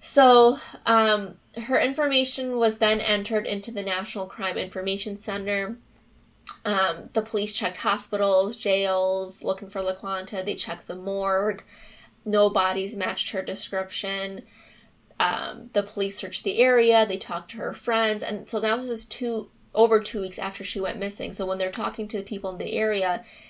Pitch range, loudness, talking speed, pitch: 195-220 Hz, -25 LUFS, 165 wpm, 205 Hz